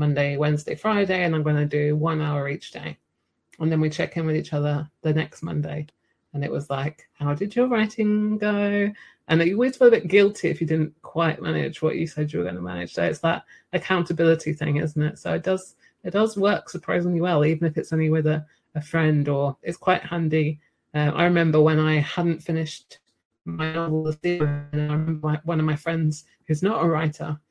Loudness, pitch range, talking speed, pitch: -23 LUFS, 150-175 Hz, 215 wpm, 160 Hz